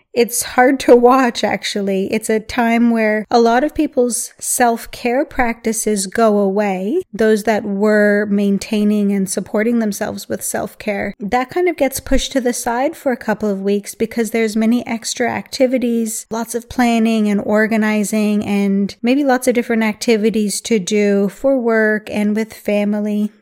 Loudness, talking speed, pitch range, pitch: -16 LUFS, 160 wpm, 210-245 Hz, 225 Hz